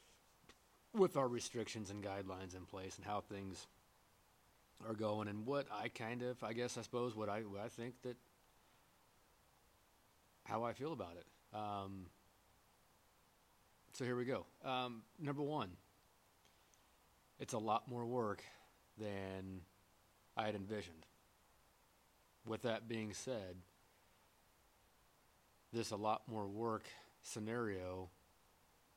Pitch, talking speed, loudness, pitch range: 105 Hz, 120 wpm, -45 LUFS, 95-120 Hz